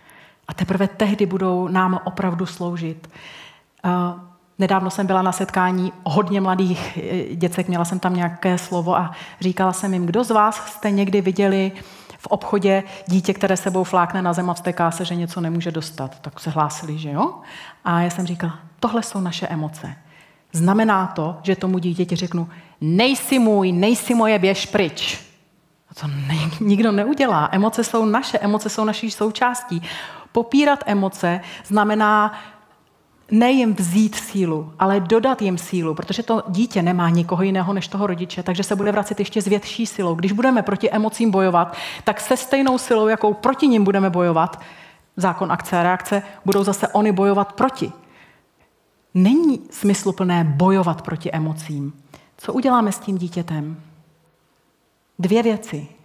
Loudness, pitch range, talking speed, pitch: -20 LUFS, 175-210 Hz, 155 wpm, 190 Hz